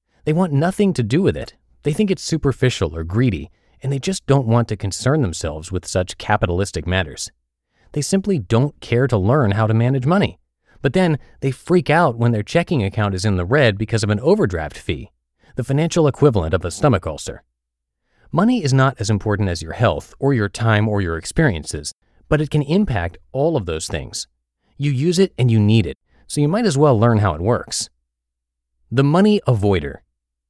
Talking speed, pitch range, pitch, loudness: 200 wpm, 95-145 Hz, 115 Hz, -19 LUFS